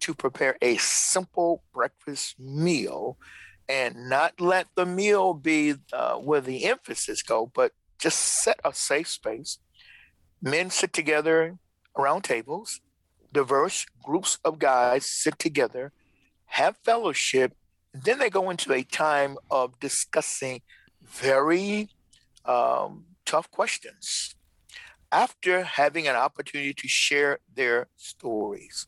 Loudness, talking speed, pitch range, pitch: -25 LUFS, 115 wpm, 140-185 Hz, 160 Hz